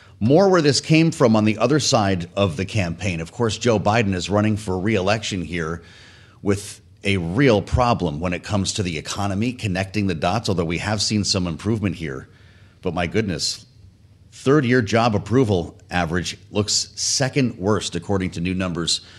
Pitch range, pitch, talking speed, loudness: 90-110 Hz, 100 Hz, 180 wpm, -21 LUFS